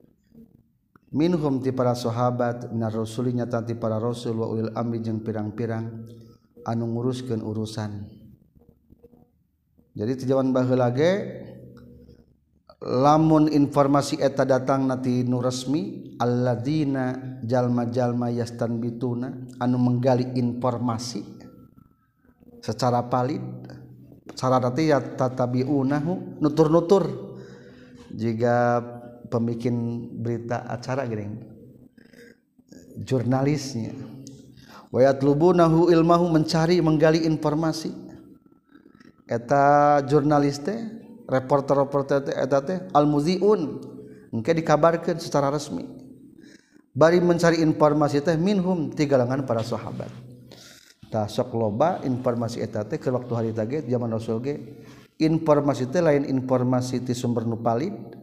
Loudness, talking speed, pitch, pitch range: -23 LUFS, 90 wpm, 125 Hz, 115-145 Hz